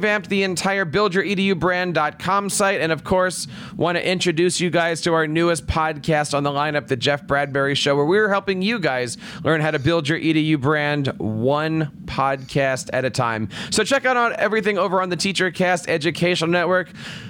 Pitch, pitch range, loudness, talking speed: 170 Hz, 150-190 Hz, -20 LUFS, 185 wpm